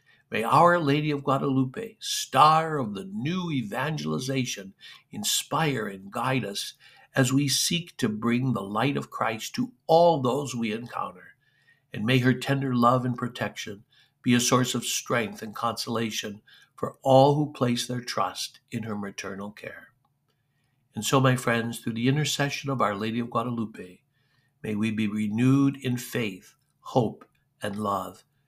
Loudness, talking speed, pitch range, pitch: -26 LUFS, 155 wpm, 110-140 Hz, 125 Hz